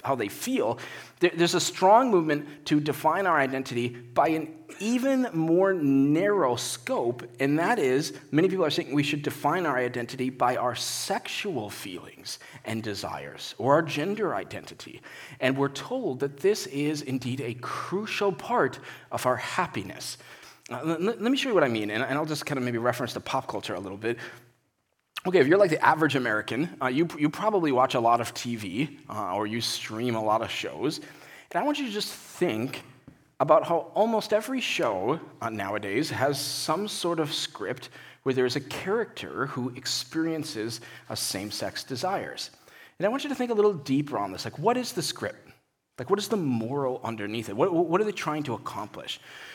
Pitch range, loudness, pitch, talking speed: 120-175 Hz, -27 LUFS, 140 Hz, 190 wpm